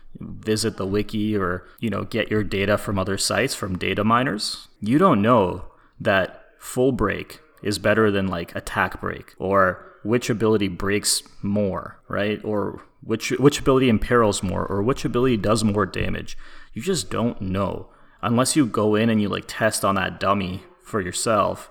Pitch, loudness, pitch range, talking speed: 105 Hz, -22 LUFS, 100-115 Hz, 170 wpm